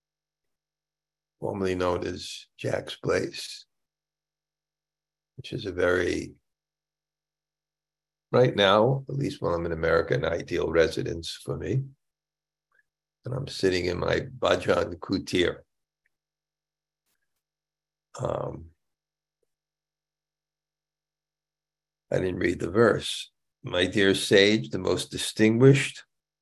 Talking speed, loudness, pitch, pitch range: 95 wpm, -26 LUFS, 155 Hz, 110-155 Hz